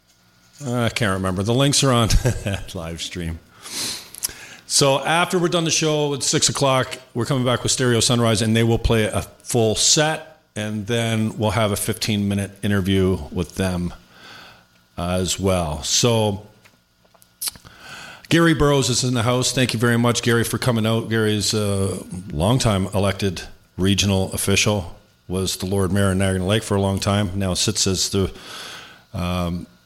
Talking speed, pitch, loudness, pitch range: 160 wpm, 105 Hz, -20 LUFS, 95-120 Hz